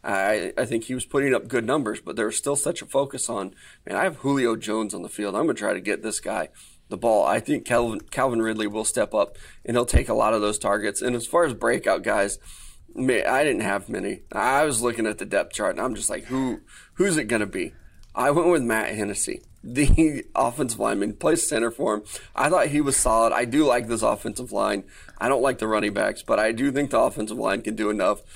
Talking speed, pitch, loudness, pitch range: 240 wpm, 120 Hz, -24 LUFS, 110-140 Hz